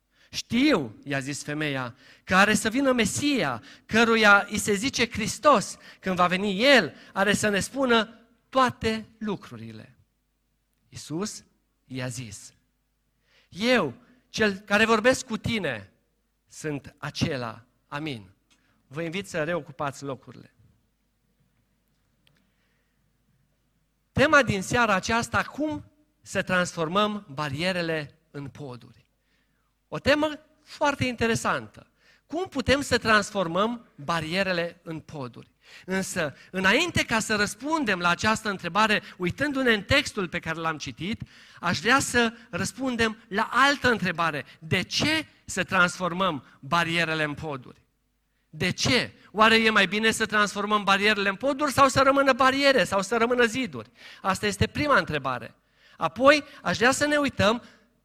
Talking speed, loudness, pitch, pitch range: 125 wpm, -24 LUFS, 205 Hz, 160-240 Hz